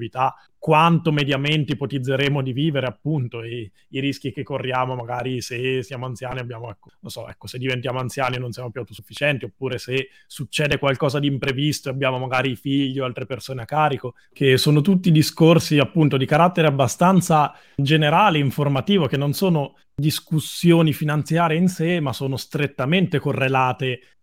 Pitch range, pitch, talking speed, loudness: 130-150 Hz, 140 Hz, 160 wpm, -20 LUFS